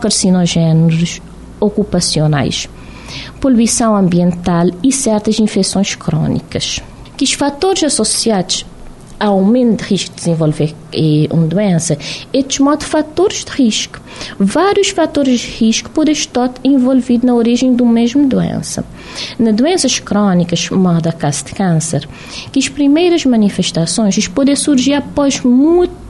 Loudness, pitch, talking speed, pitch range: -13 LUFS, 220 Hz, 120 wpm, 175-270 Hz